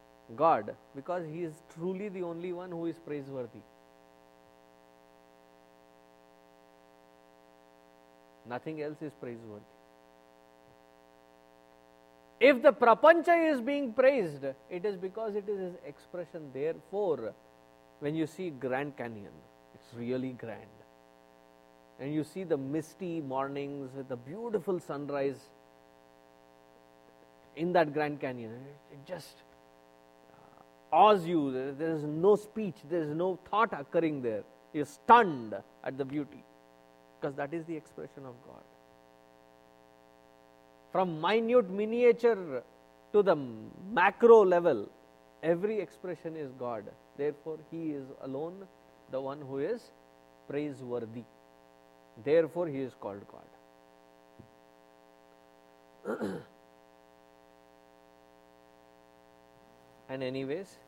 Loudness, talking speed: -31 LUFS, 105 wpm